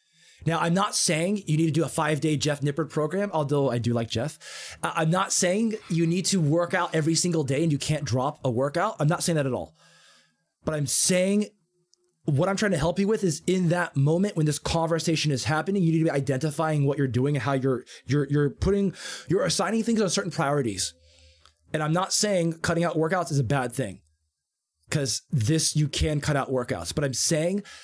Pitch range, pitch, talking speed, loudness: 140-175 Hz, 155 Hz, 220 wpm, -25 LUFS